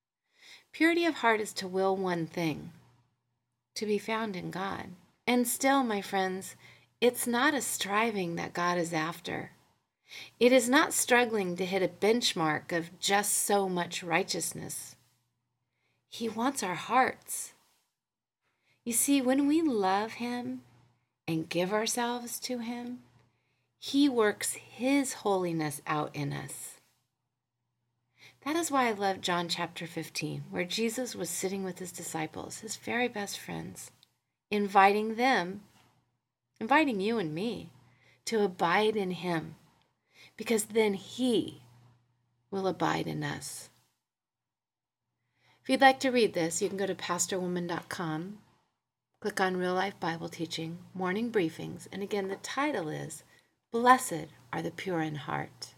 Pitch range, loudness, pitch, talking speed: 160-225 Hz, -30 LUFS, 190 Hz, 135 wpm